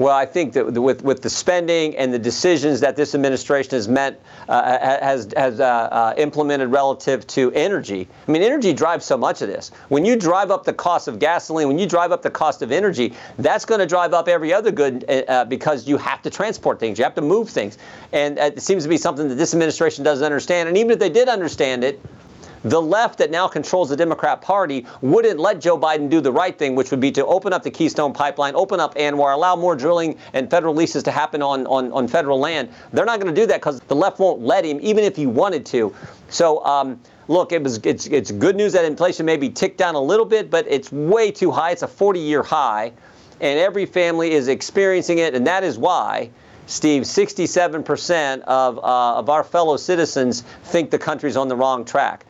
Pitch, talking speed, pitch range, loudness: 150 Hz, 225 wpm, 135-175 Hz, -19 LUFS